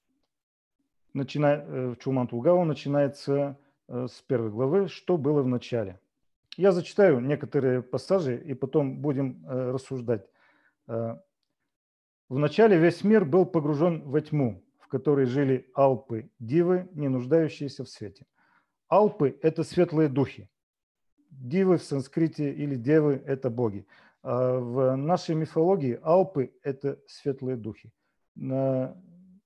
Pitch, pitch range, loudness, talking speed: 140 Hz, 130-165 Hz, -26 LUFS, 115 wpm